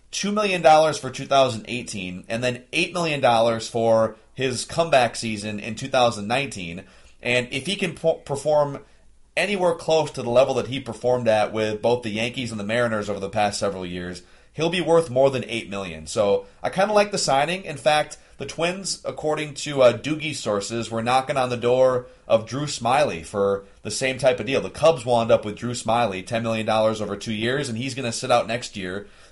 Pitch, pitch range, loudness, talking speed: 120 Hz, 105-140 Hz, -22 LUFS, 205 wpm